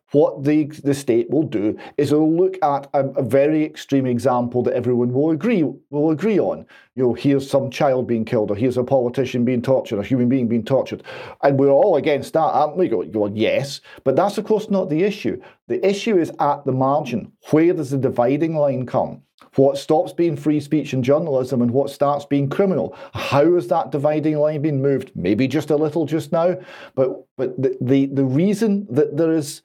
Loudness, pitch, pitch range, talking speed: -19 LUFS, 140 Hz, 130-160 Hz, 210 wpm